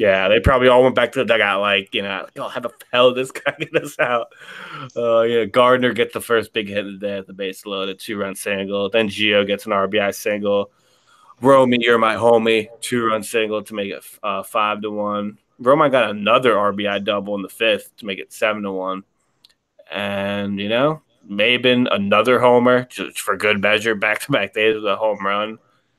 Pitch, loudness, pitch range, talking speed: 105 Hz, -18 LUFS, 100-115 Hz, 210 wpm